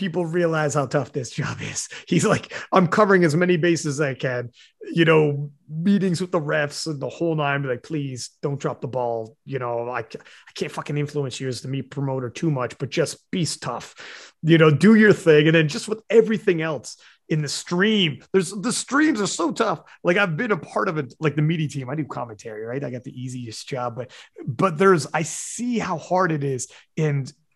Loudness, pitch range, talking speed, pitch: -22 LUFS, 135-180 Hz, 220 wpm, 155 Hz